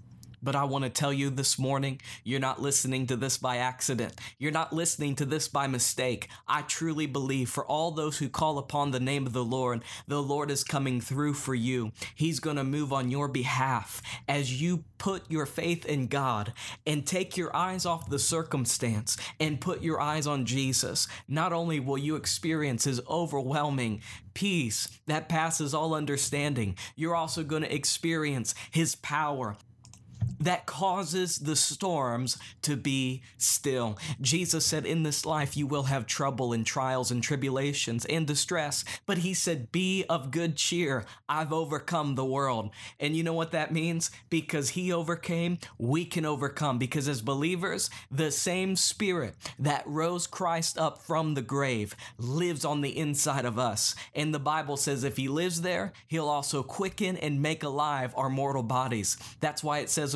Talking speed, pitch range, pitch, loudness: 175 wpm, 130-160 Hz, 145 Hz, -30 LUFS